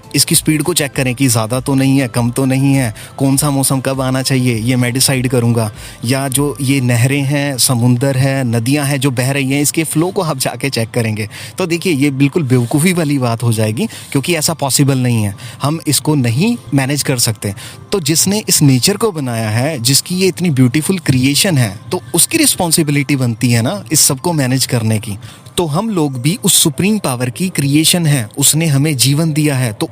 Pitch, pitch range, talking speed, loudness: 140 Hz, 125-155 Hz, 210 wpm, -13 LUFS